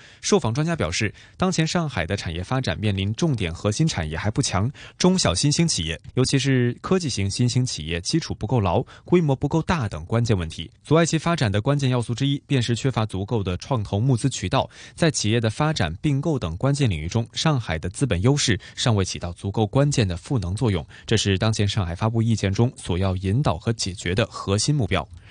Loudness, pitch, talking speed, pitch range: -23 LUFS, 115 Hz, 330 characters per minute, 100-140 Hz